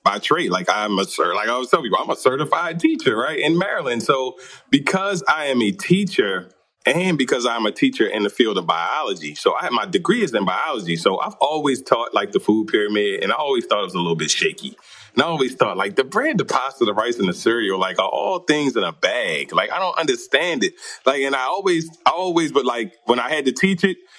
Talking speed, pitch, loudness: 245 wpm, 190 Hz, -20 LUFS